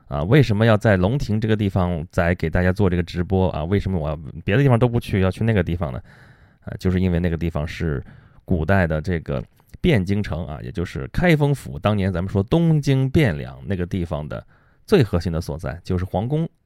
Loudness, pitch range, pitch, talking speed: -21 LUFS, 85-110 Hz, 95 Hz, 320 characters per minute